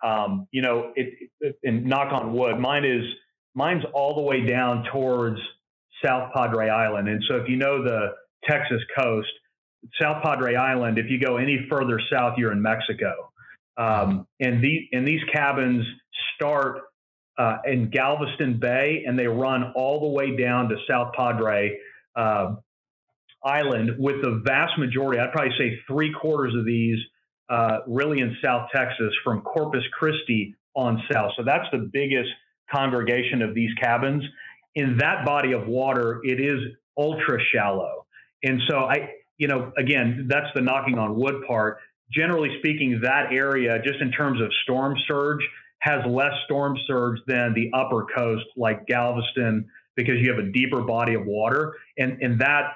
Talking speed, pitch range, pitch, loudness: 165 wpm, 120-140 Hz, 125 Hz, -24 LUFS